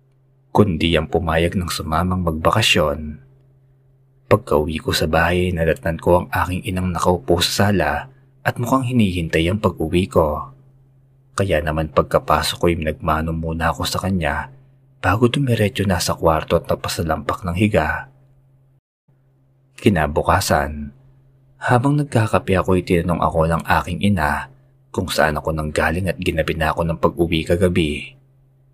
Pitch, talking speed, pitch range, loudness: 90 Hz, 135 wpm, 80-135 Hz, -19 LUFS